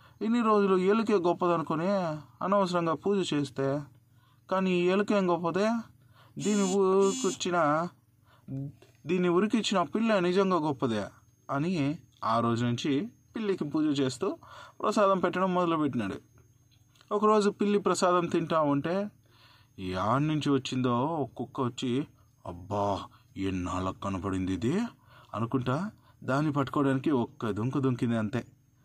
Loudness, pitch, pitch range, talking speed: -29 LUFS, 145 Hz, 120-185 Hz, 100 wpm